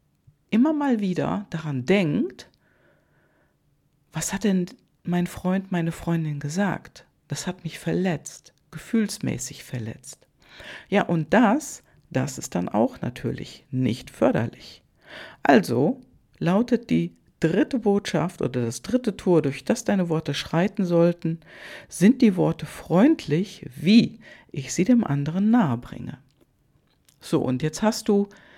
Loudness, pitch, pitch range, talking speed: -24 LUFS, 170 Hz, 150-205 Hz, 125 wpm